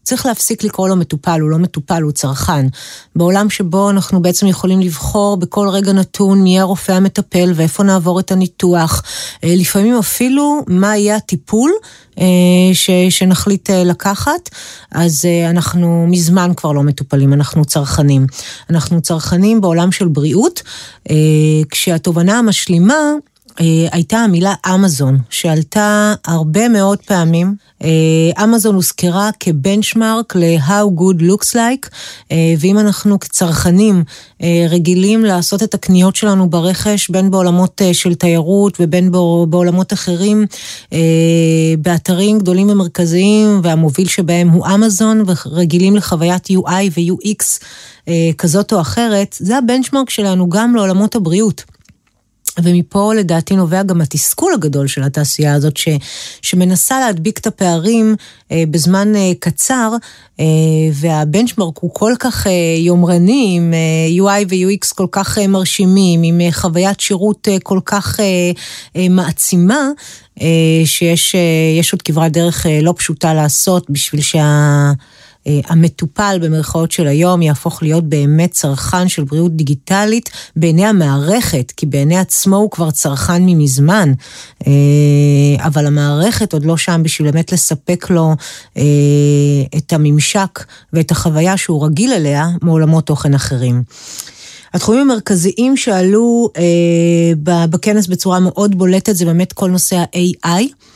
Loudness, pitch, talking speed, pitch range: -12 LUFS, 180 Hz, 115 wpm, 160-200 Hz